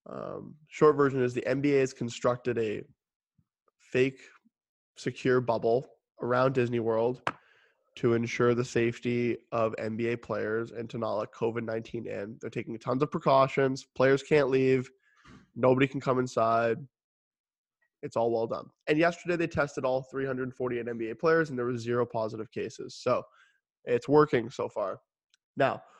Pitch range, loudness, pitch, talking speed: 115-135 Hz, -29 LUFS, 125 Hz, 150 wpm